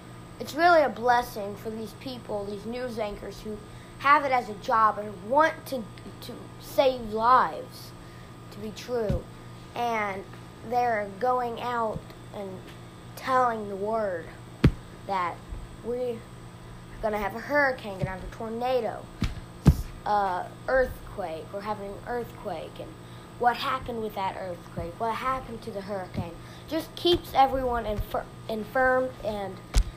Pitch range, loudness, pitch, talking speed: 205-255 Hz, -28 LUFS, 230 Hz, 135 wpm